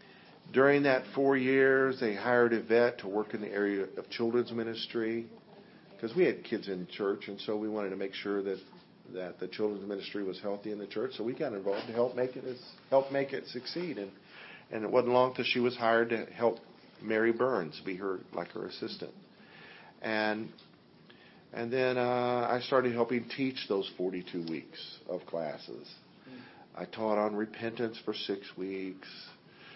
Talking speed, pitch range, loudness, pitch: 180 wpm, 100-125 Hz, -32 LUFS, 115 Hz